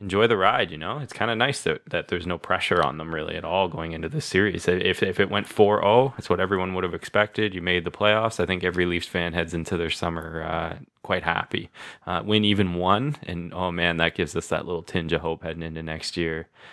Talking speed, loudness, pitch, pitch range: 250 wpm, -24 LUFS, 90 Hz, 80-95 Hz